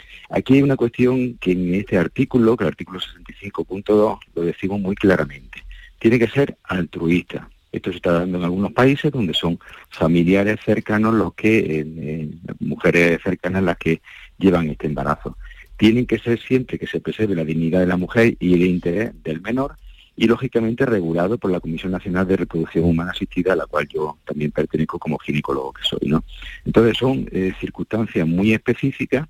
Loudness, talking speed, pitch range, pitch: -20 LUFS, 180 wpm, 85-115 Hz, 95 Hz